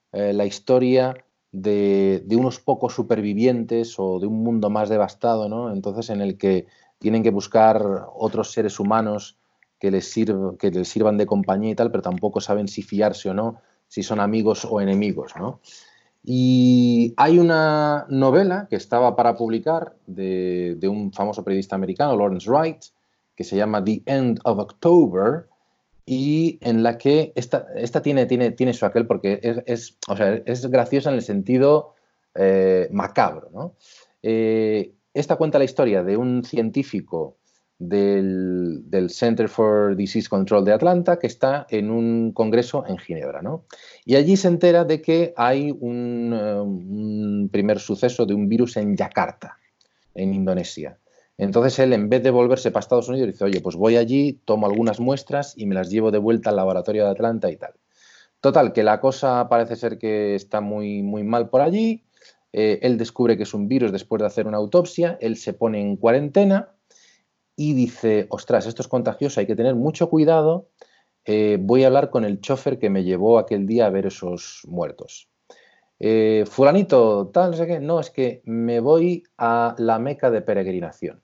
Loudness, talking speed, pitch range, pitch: -20 LUFS, 175 wpm, 105-130 Hz, 115 Hz